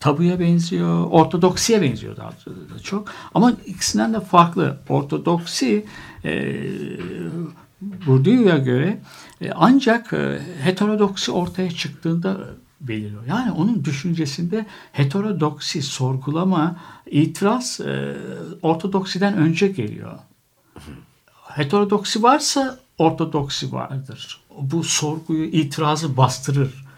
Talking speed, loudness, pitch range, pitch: 85 wpm, -20 LUFS, 145-200 Hz, 165 Hz